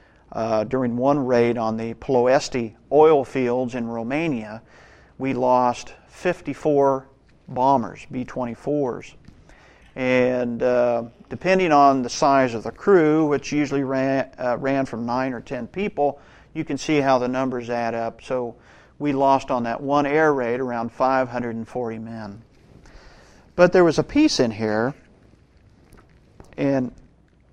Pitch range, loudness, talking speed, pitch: 120-140 Hz, -21 LUFS, 135 wpm, 130 Hz